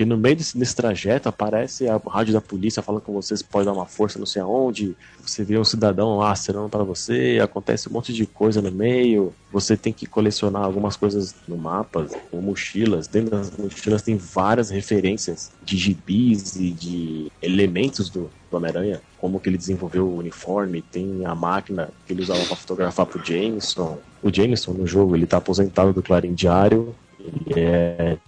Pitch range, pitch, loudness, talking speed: 90-110 Hz, 100 Hz, -22 LUFS, 185 wpm